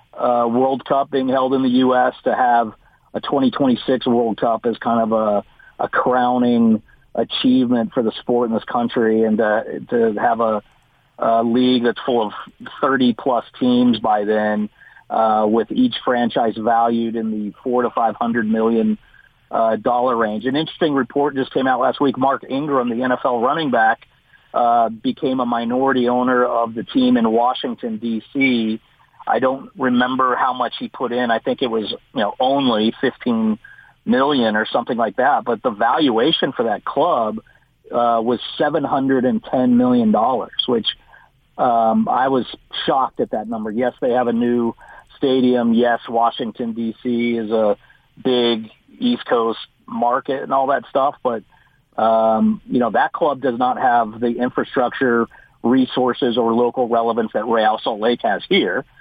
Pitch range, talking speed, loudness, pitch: 115-130 Hz, 170 wpm, -18 LUFS, 120 Hz